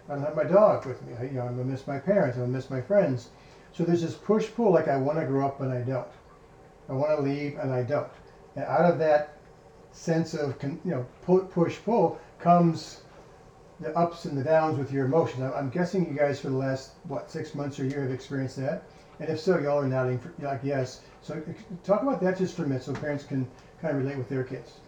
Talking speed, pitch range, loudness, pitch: 235 wpm, 135-165 Hz, -28 LUFS, 150 Hz